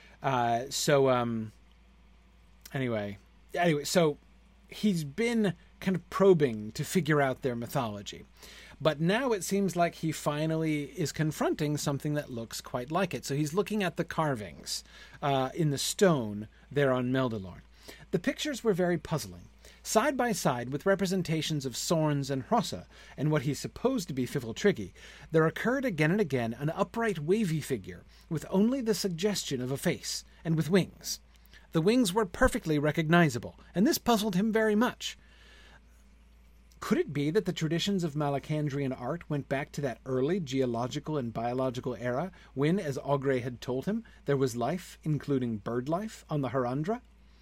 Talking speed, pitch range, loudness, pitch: 160 wpm, 130-185 Hz, -30 LUFS, 150 Hz